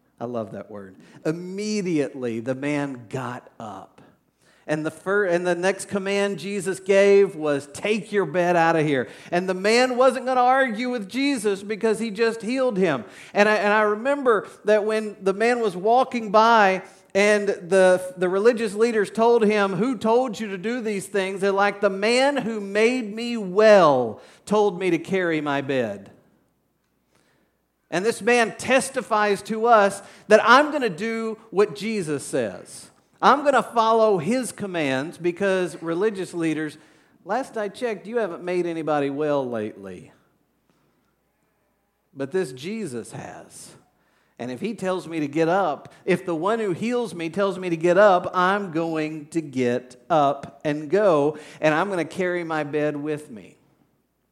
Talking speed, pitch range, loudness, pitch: 165 wpm, 160-220 Hz, -22 LUFS, 195 Hz